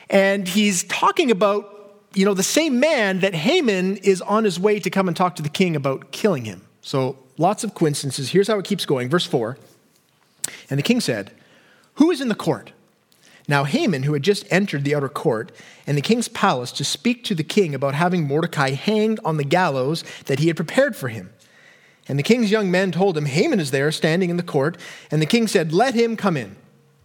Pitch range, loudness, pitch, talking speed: 150-205 Hz, -20 LUFS, 185 Hz, 215 wpm